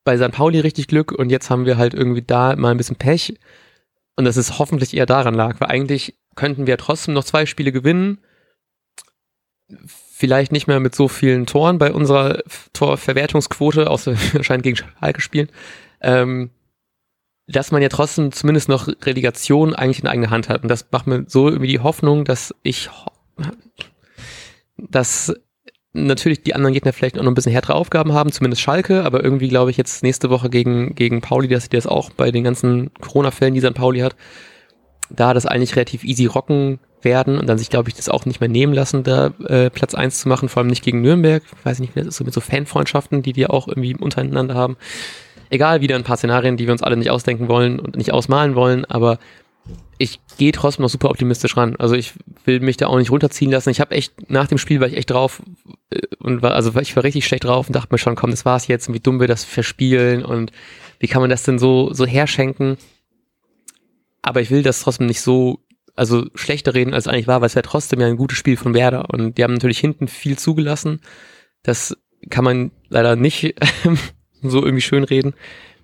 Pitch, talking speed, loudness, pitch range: 130 Hz, 210 wpm, -17 LUFS, 125-145 Hz